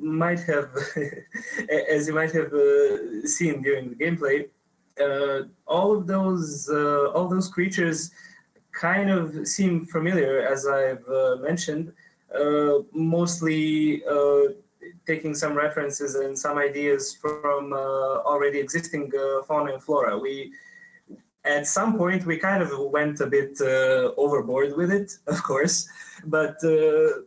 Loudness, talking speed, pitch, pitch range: -24 LUFS, 135 wpm, 155 Hz, 140-185 Hz